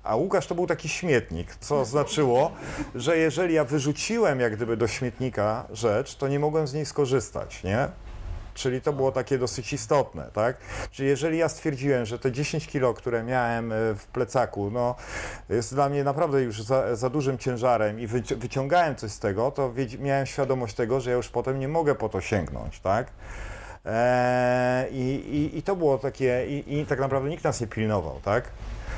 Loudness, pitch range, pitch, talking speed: -26 LUFS, 115-145 Hz, 130 Hz, 180 wpm